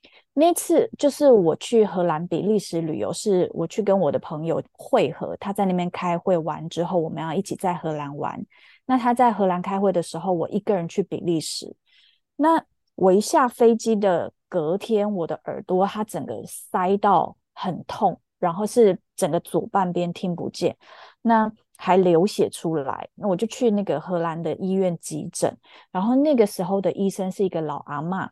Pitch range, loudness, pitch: 170-215 Hz, -23 LUFS, 190 Hz